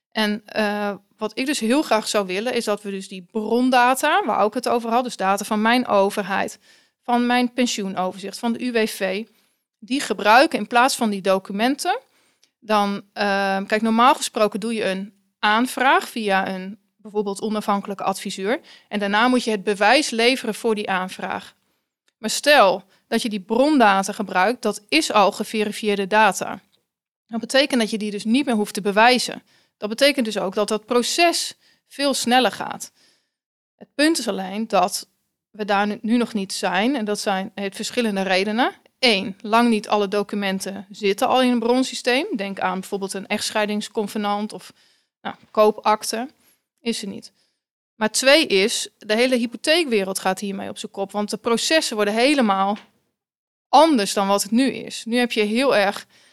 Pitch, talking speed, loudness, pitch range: 215 Hz, 170 wpm, -20 LUFS, 205-245 Hz